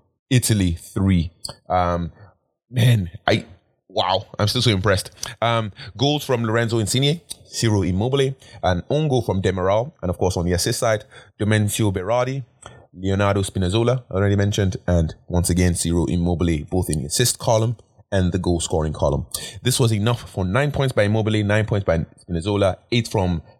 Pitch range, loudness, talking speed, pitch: 90-120 Hz, -21 LUFS, 165 wpm, 105 Hz